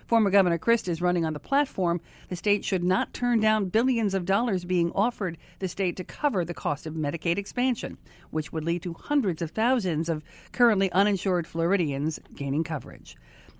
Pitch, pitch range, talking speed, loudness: 180 Hz, 165-210 Hz, 180 wpm, -27 LUFS